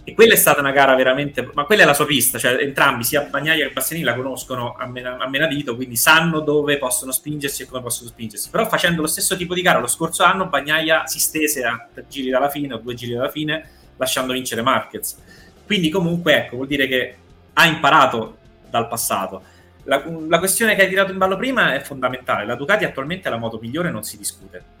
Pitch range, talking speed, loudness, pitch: 125-160 Hz, 220 wpm, -18 LUFS, 140 Hz